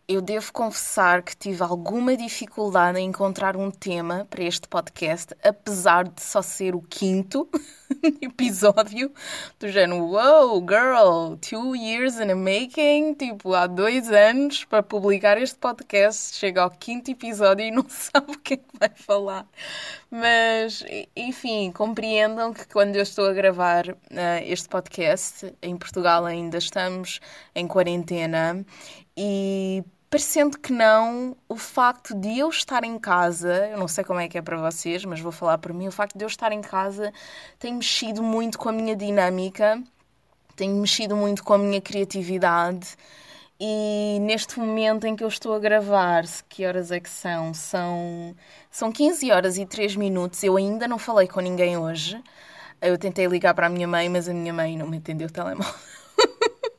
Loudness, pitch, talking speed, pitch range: -23 LUFS, 205 Hz, 170 wpm, 180-230 Hz